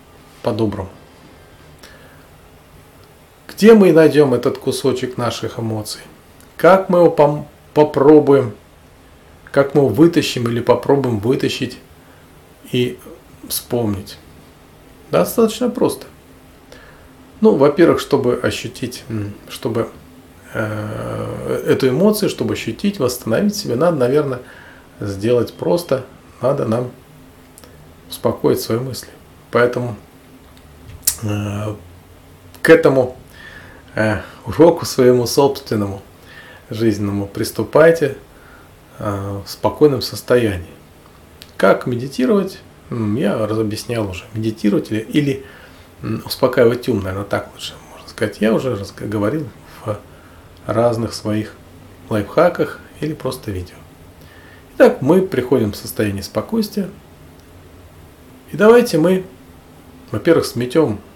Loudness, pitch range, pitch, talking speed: -17 LUFS, 90-135 Hz, 110 Hz, 90 wpm